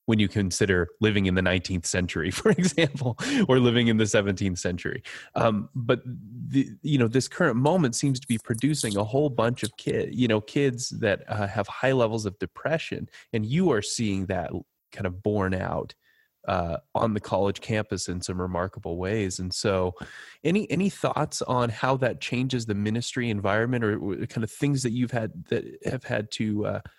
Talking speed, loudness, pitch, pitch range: 190 wpm, -26 LUFS, 110 Hz, 100-125 Hz